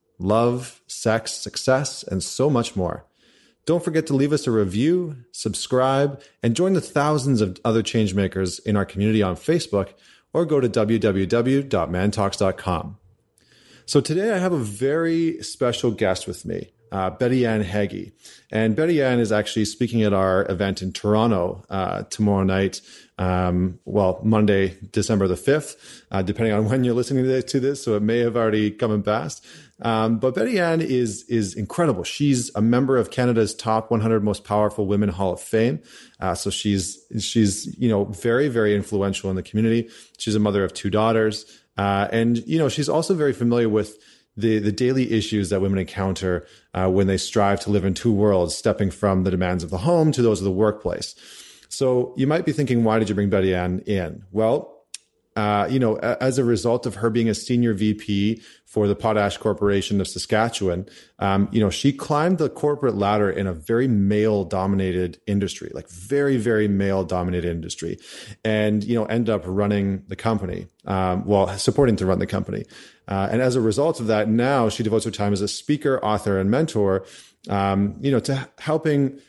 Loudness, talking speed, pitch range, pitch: -22 LUFS, 185 wpm, 100-120 Hz, 110 Hz